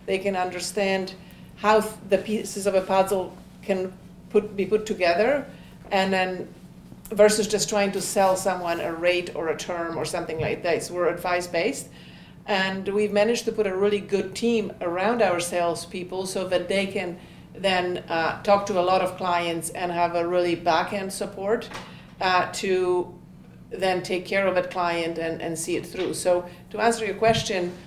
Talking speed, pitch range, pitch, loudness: 180 wpm, 175-200 Hz, 185 Hz, -24 LUFS